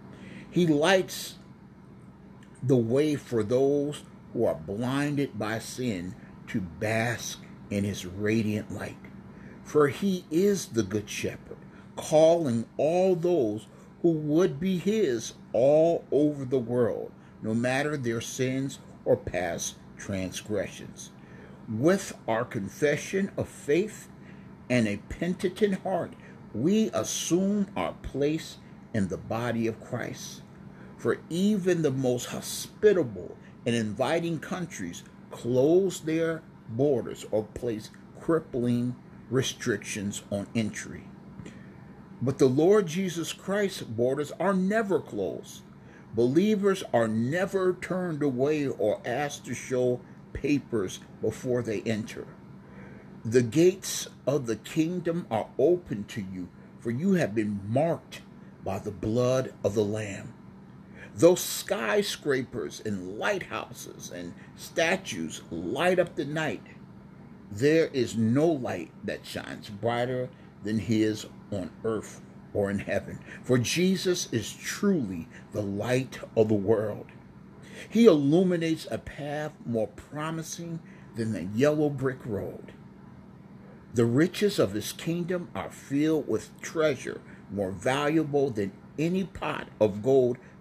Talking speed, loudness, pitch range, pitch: 120 wpm, -28 LUFS, 110-170 Hz, 135 Hz